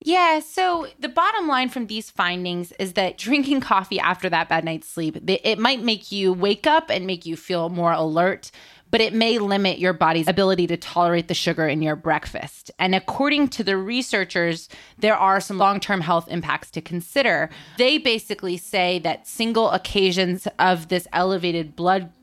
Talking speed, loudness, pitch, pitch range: 180 wpm, -21 LUFS, 190 Hz, 175-225 Hz